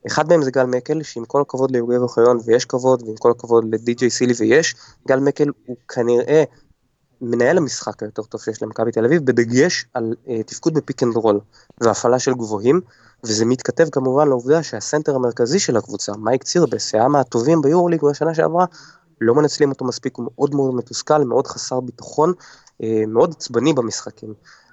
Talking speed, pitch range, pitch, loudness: 170 wpm, 115-145 Hz, 125 Hz, -18 LUFS